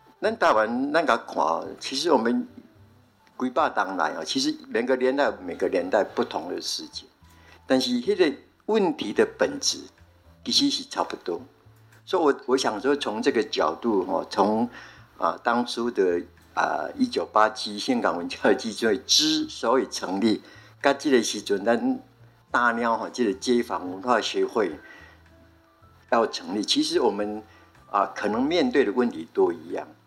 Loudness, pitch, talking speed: -25 LUFS, 120 Hz, 225 characters per minute